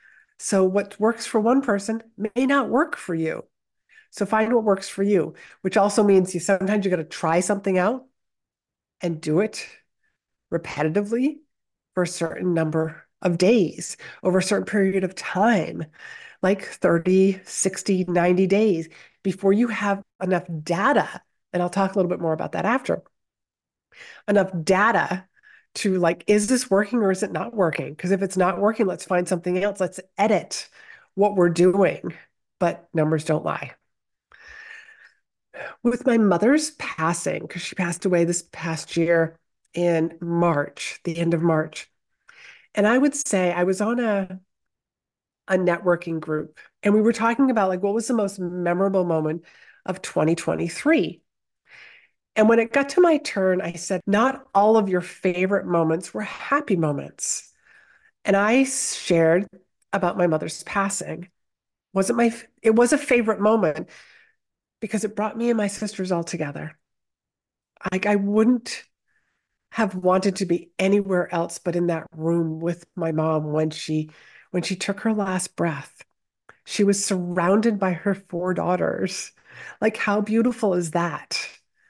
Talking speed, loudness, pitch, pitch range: 155 wpm, -23 LUFS, 190 Hz, 175-215 Hz